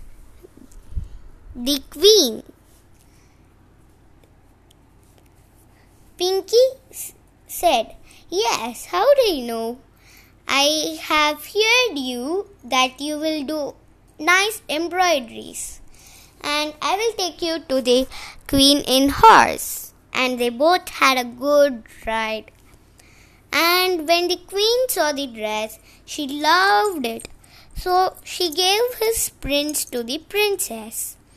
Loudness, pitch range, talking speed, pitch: -19 LUFS, 230-360 Hz, 105 wpm, 290 Hz